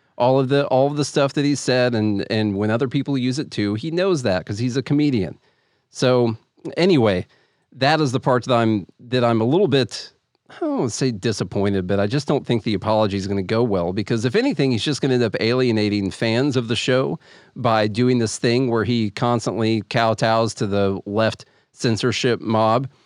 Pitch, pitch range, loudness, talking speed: 120 Hz, 110-130 Hz, -20 LUFS, 205 wpm